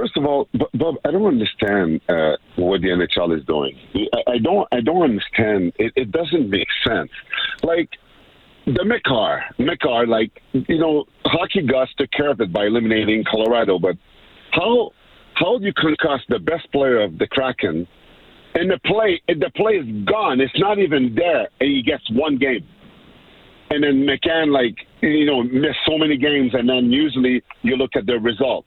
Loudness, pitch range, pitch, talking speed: -19 LUFS, 110-145 Hz, 130 Hz, 190 wpm